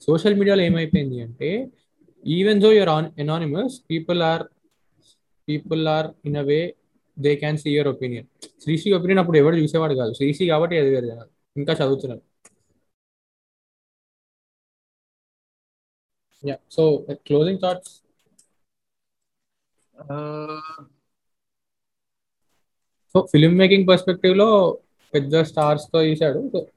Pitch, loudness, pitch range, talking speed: 155 Hz, -20 LUFS, 145-180 Hz, 95 wpm